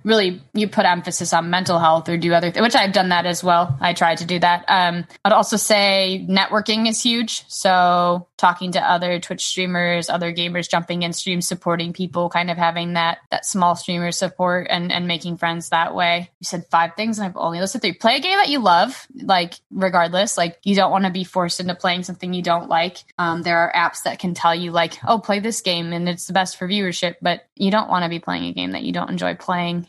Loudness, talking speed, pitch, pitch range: -19 LUFS, 240 wpm, 175 Hz, 170-190 Hz